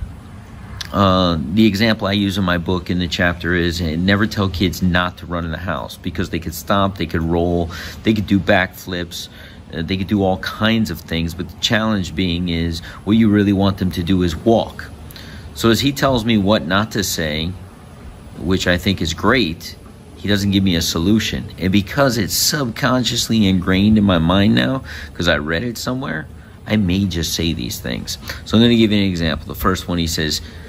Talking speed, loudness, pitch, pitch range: 210 wpm, -18 LUFS, 95 Hz, 85-105 Hz